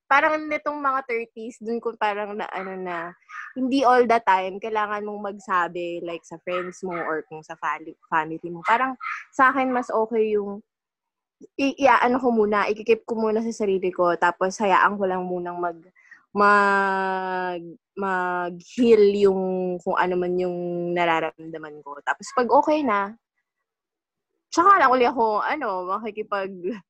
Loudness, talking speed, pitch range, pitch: -23 LUFS, 150 wpm, 180-230 Hz, 200 Hz